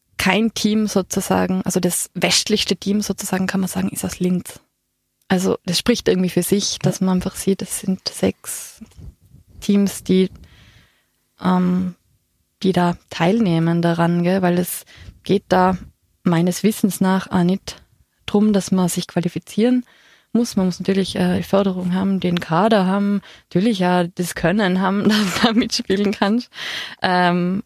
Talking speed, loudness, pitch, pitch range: 150 wpm, -19 LUFS, 185 Hz, 180-200 Hz